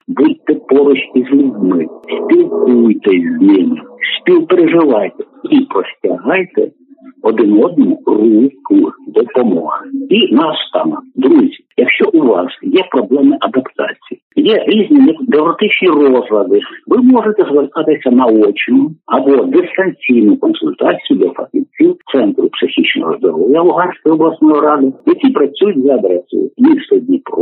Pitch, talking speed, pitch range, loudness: 300 Hz, 105 wpm, 255-350 Hz, -11 LUFS